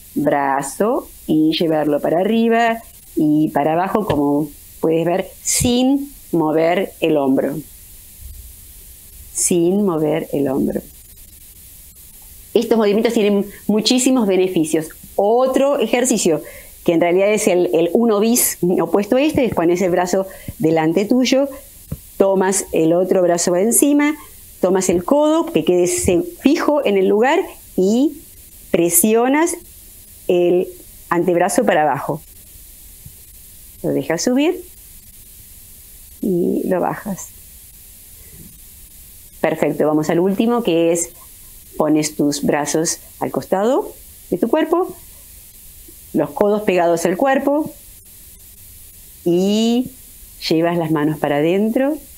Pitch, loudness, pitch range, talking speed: 180 Hz, -17 LUFS, 145-230 Hz, 110 wpm